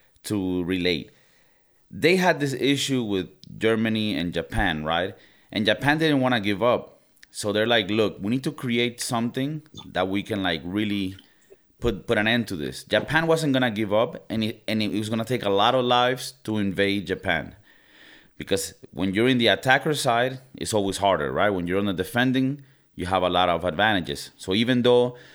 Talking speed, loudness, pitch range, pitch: 200 wpm, -24 LUFS, 95-125 Hz, 110 Hz